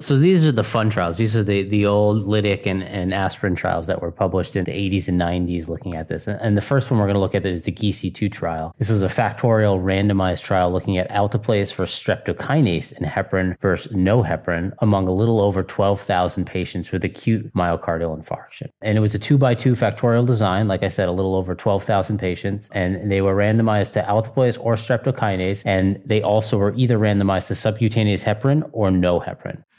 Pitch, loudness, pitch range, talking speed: 100 Hz, -20 LUFS, 95-110 Hz, 205 wpm